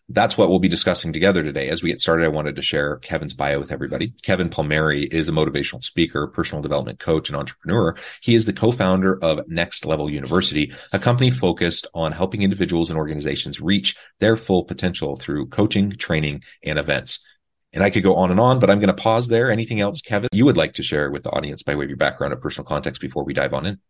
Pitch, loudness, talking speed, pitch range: 95 Hz, -20 LUFS, 235 wpm, 80-105 Hz